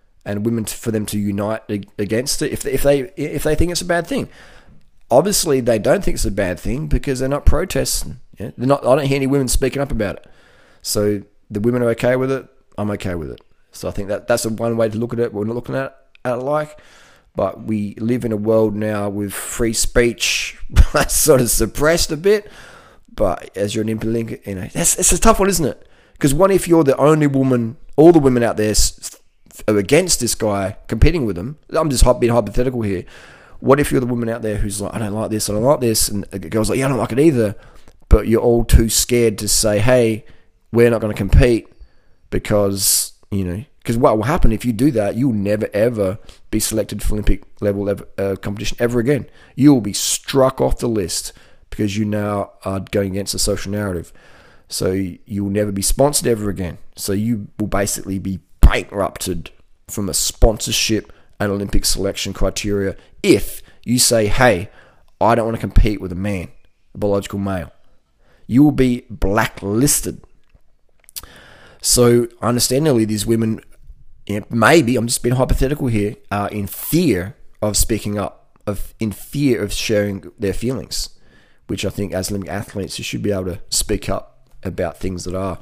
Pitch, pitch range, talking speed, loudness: 110 Hz, 100-125 Hz, 200 wpm, -18 LUFS